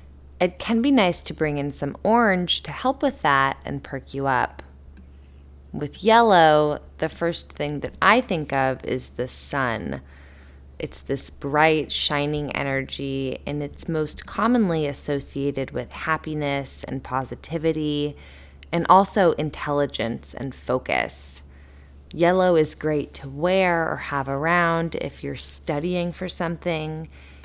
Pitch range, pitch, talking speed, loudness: 130-170 Hz, 145 Hz, 135 wpm, -23 LUFS